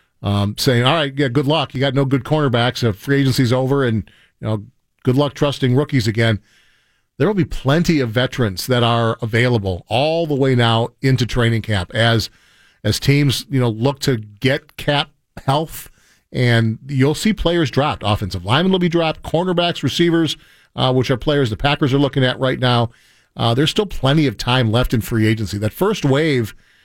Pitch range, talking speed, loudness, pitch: 115-145 Hz, 190 wpm, -17 LUFS, 130 Hz